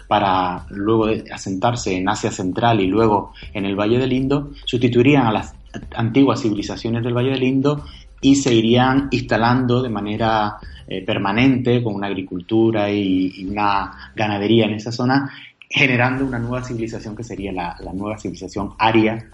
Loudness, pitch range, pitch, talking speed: -19 LUFS, 100-125 Hz, 110 Hz, 160 wpm